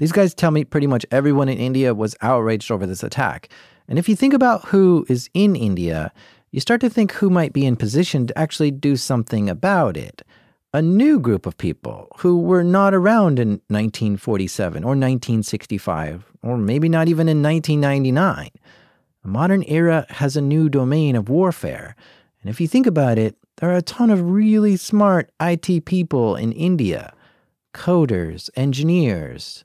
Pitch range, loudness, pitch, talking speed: 115-180 Hz, -18 LUFS, 150 Hz, 170 wpm